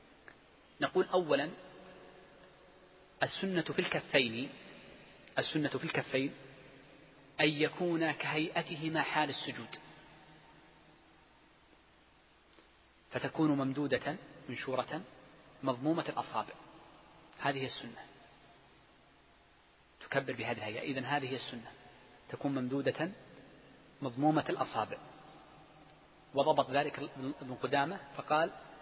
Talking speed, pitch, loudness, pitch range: 75 wpm, 145 Hz, -35 LUFS, 135-155 Hz